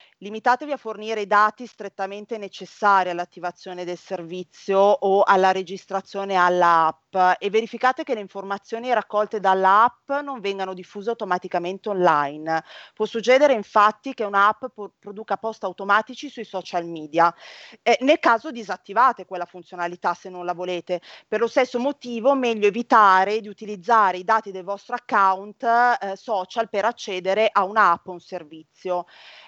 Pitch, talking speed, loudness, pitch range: 200 Hz, 140 wpm, -21 LUFS, 185-230 Hz